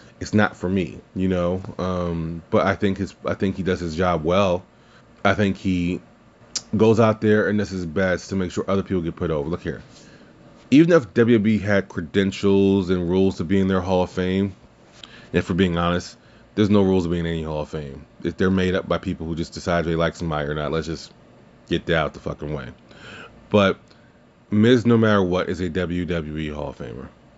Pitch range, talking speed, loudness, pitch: 85-105 Hz, 215 wpm, -22 LUFS, 95 Hz